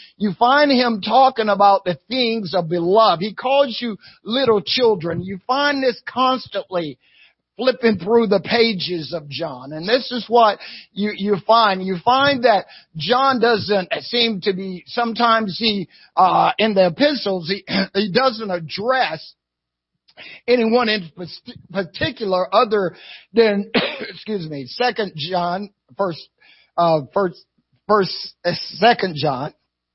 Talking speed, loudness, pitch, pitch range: 130 wpm, -18 LUFS, 205 Hz, 175-235 Hz